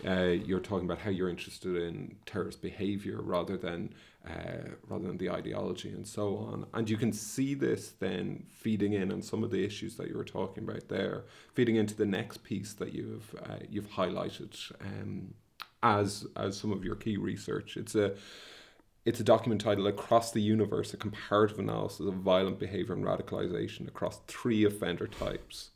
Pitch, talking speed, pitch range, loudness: 100 Hz, 180 wpm, 95-110 Hz, -34 LUFS